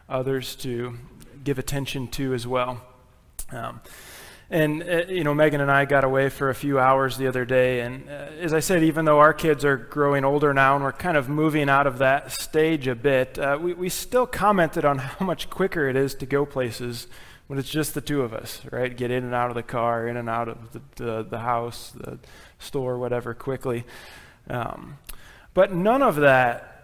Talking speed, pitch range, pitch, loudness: 210 wpm, 125-150 Hz, 135 Hz, -23 LUFS